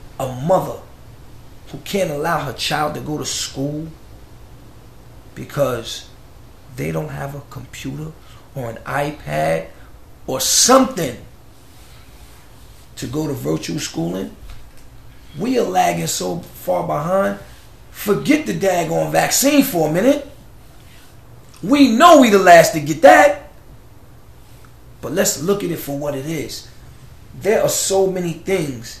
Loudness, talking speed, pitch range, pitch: -17 LUFS, 130 wpm, 120-180 Hz, 140 Hz